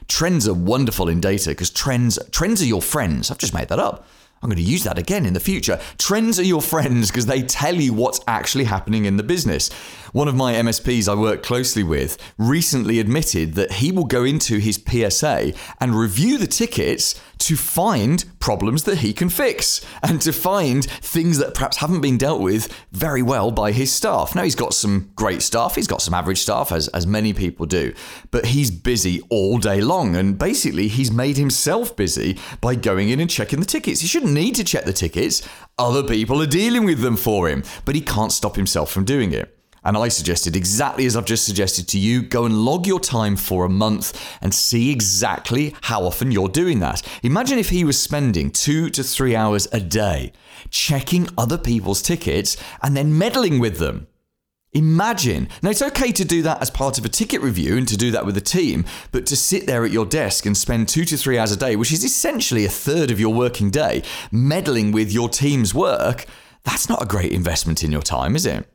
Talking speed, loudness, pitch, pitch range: 215 wpm, -19 LUFS, 120 Hz, 105-145 Hz